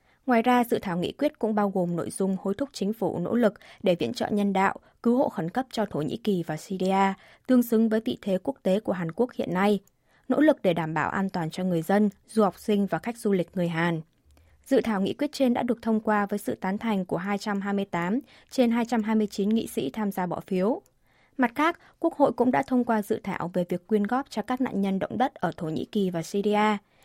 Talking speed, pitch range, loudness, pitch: 250 wpm, 185-235 Hz, -26 LUFS, 205 Hz